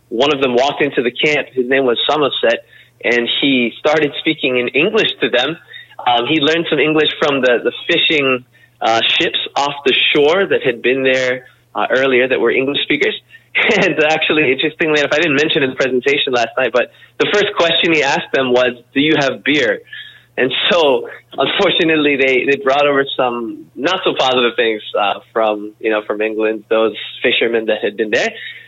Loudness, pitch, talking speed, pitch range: -14 LUFS, 140 Hz, 190 wpm, 125-165 Hz